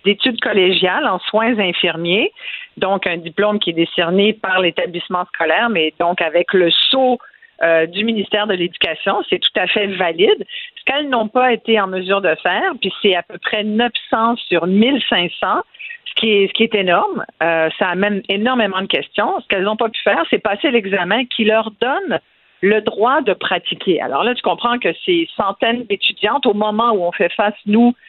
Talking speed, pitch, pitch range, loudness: 190 wpm, 210 Hz, 185-235 Hz, -16 LUFS